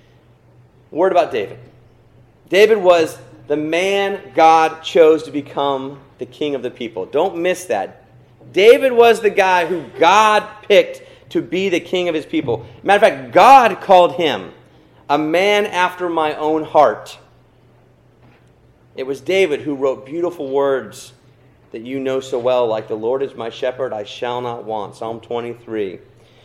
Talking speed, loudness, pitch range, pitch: 155 wpm, -16 LUFS, 125-180 Hz, 150 Hz